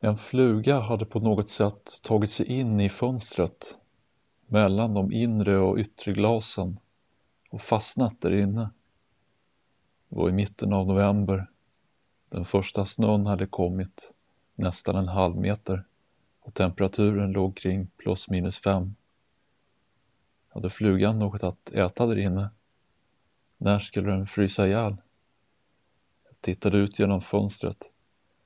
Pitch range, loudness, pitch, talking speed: 95-105 Hz, -26 LUFS, 100 Hz, 125 wpm